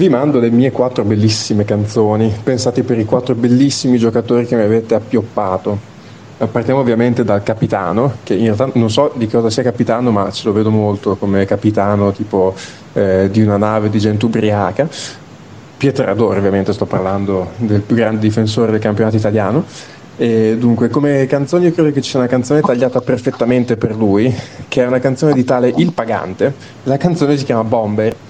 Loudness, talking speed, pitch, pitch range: -14 LUFS, 180 wpm, 115 Hz, 105-130 Hz